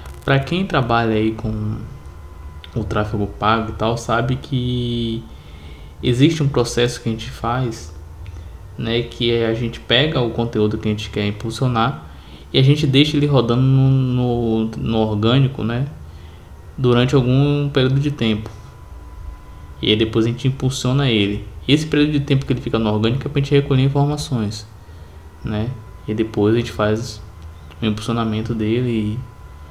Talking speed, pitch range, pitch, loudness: 160 wpm, 105-125 Hz, 115 Hz, -19 LUFS